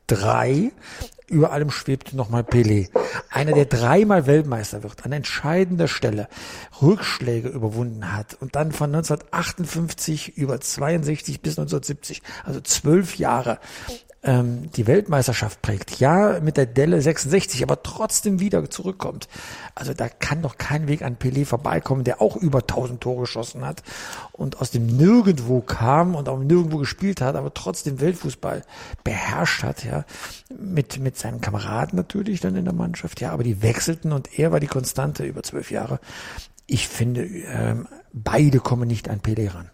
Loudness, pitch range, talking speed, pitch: -22 LUFS, 120-160 Hz, 155 wpm, 135 Hz